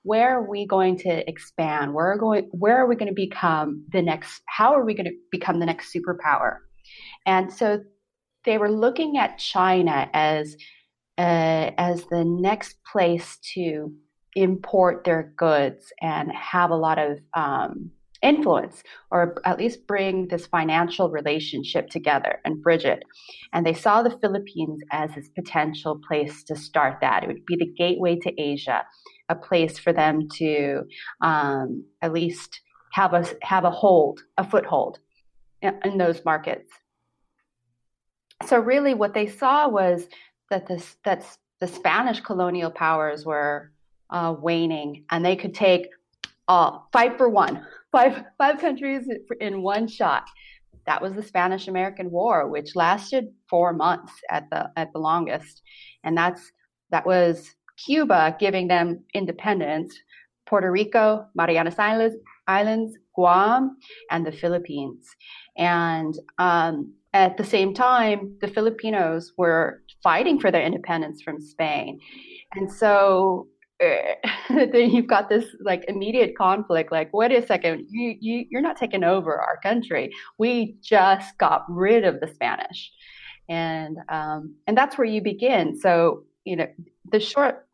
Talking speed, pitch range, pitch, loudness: 150 wpm, 165-215 Hz, 180 Hz, -23 LUFS